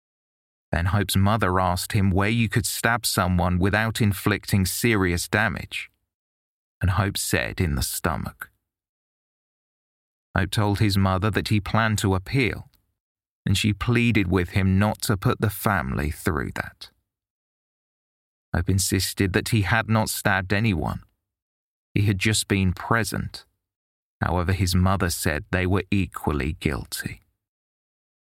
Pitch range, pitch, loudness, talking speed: 95-110 Hz, 100 Hz, -23 LUFS, 130 wpm